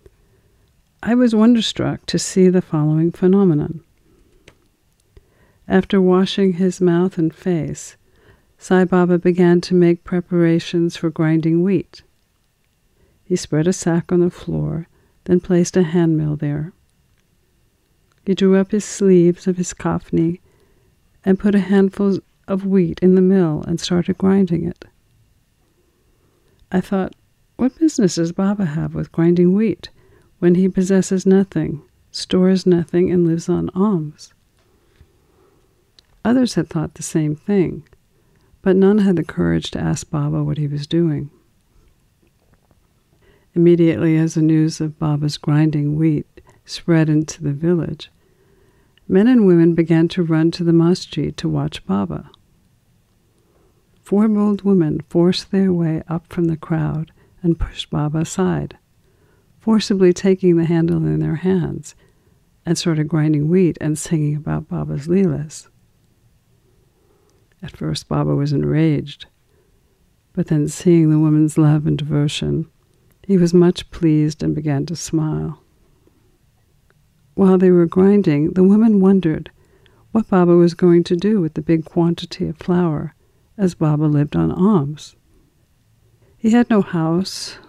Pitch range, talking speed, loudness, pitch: 155-185 Hz, 135 wpm, -17 LUFS, 170 Hz